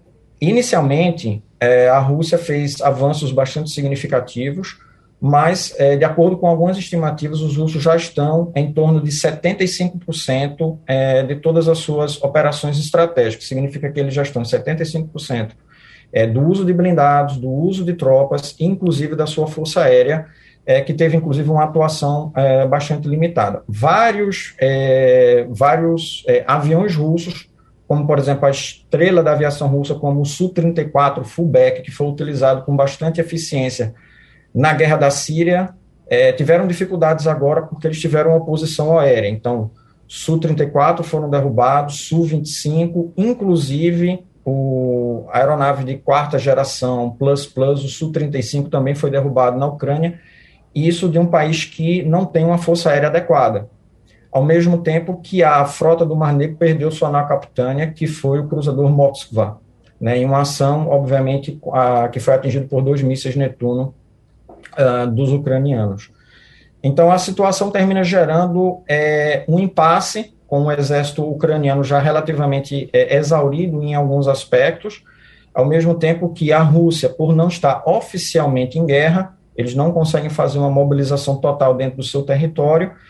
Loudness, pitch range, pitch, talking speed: -16 LUFS, 135-165 Hz, 150 Hz, 145 wpm